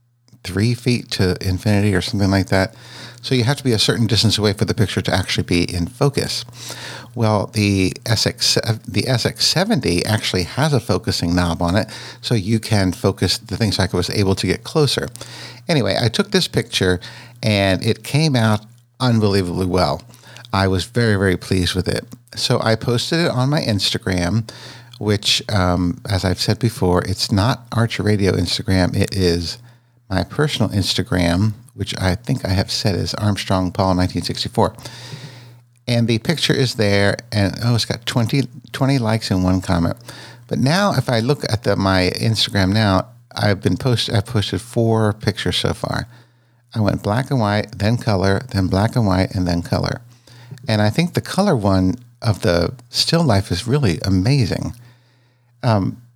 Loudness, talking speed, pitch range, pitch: -18 LUFS, 175 wpm, 95-125 Hz, 110 Hz